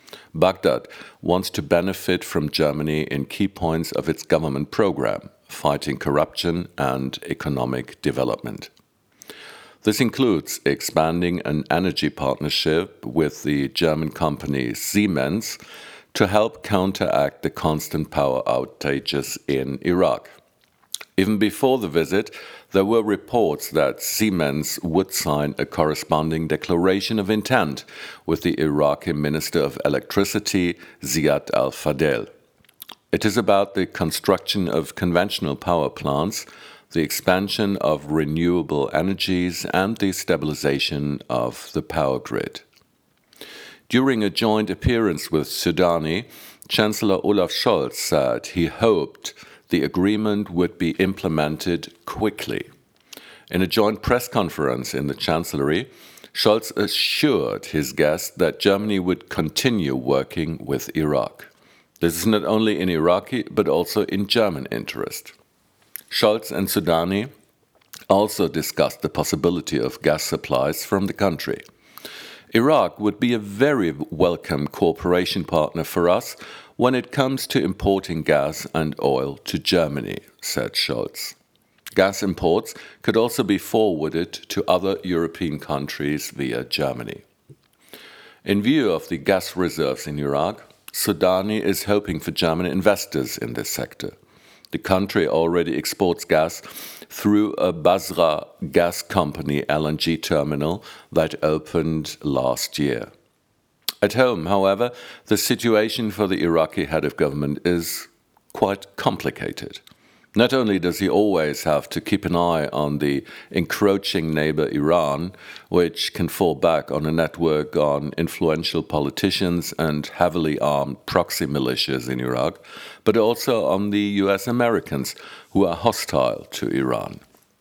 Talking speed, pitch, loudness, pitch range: 125 wpm, 90 Hz, -22 LUFS, 75-100 Hz